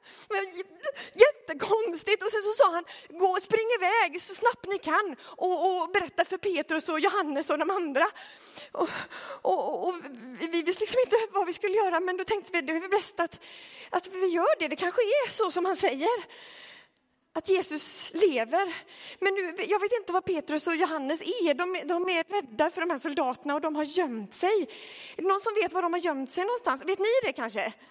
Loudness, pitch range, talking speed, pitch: -28 LUFS, 330-405 Hz, 205 wpm, 365 Hz